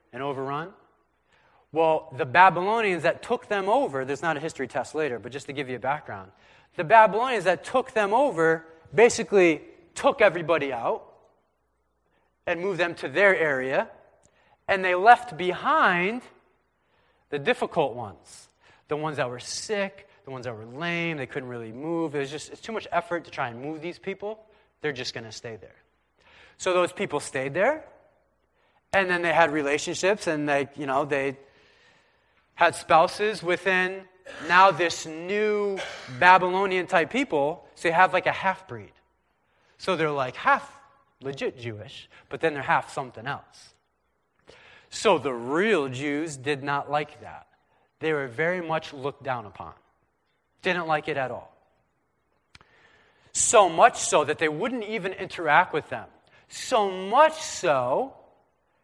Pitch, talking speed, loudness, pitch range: 170 Hz, 155 wpm, -24 LUFS, 145-195 Hz